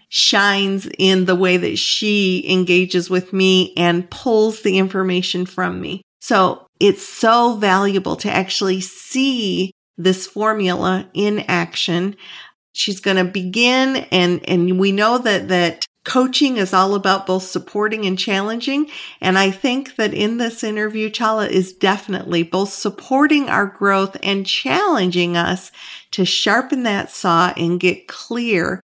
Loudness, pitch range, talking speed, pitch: -17 LUFS, 185-215 Hz, 140 wpm, 195 Hz